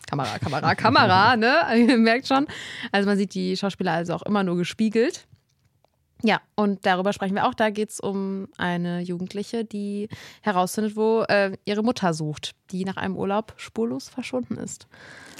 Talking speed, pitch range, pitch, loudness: 170 wpm, 185-225 Hz, 205 Hz, -23 LUFS